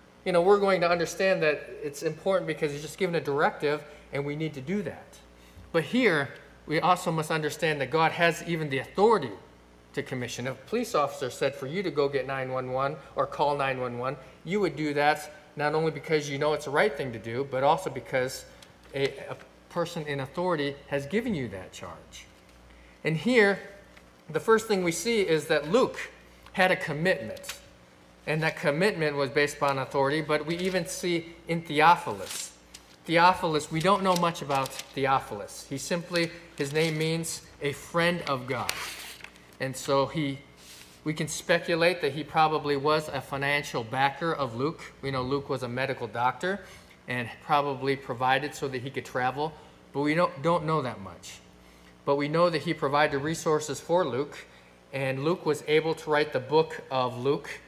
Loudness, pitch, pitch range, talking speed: -28 LUFS, 150 Hz, 130-165 Hz, 180 wpm